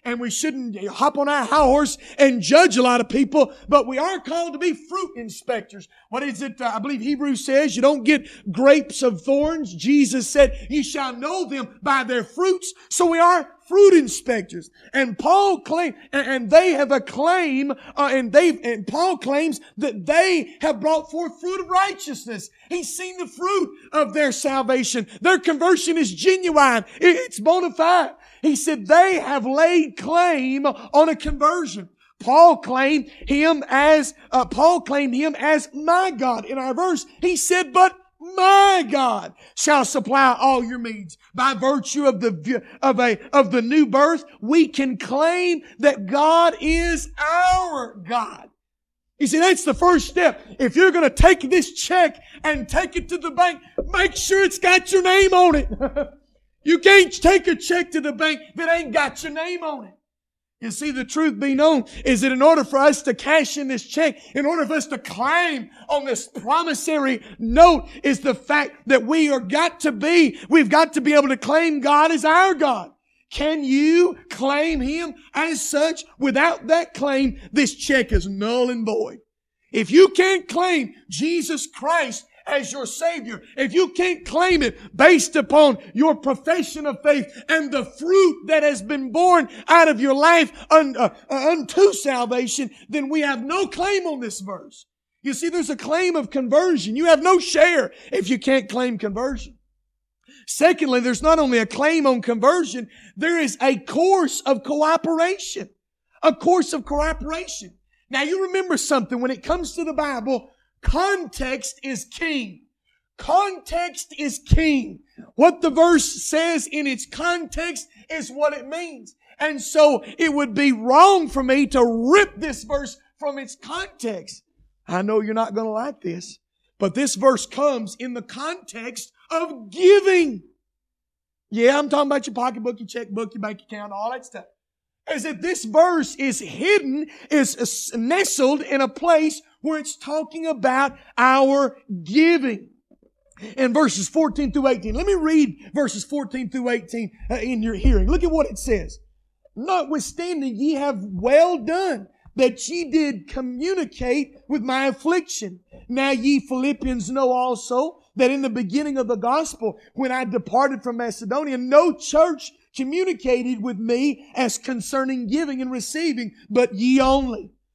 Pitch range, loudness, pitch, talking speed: 255-325 Hz, -19 LUFS, 285 Hz, 165 wpm